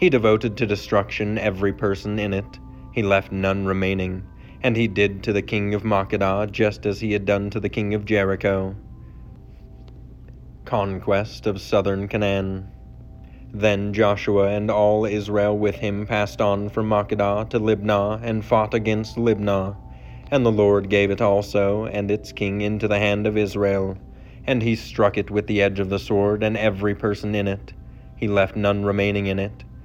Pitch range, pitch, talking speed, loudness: 100-105 Hz, 105 Hz, 175 wpm, -22 LUFS